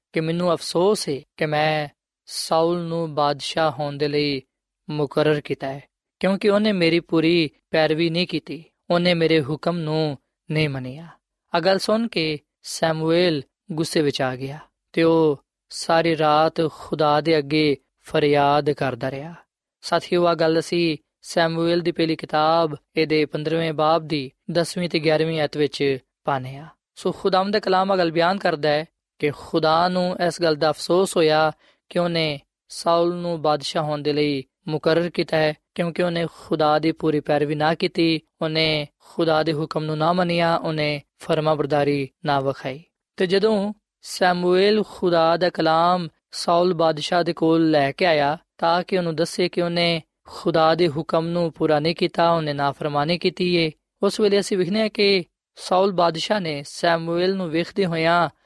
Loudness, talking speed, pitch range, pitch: -21 LUFS, 155 wpm, 150-175 Hz, 165 Hz